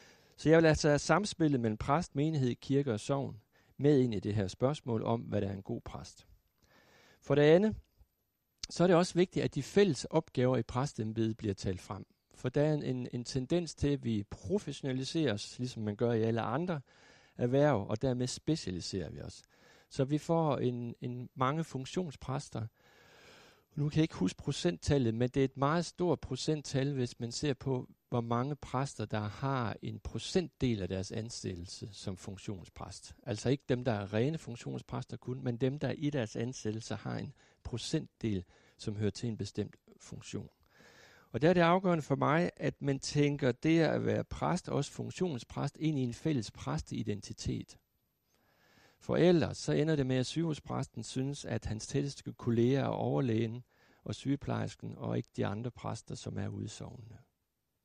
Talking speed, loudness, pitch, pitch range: 175 wpm, -34 LUFS, 125 Hz, 110-145 Hz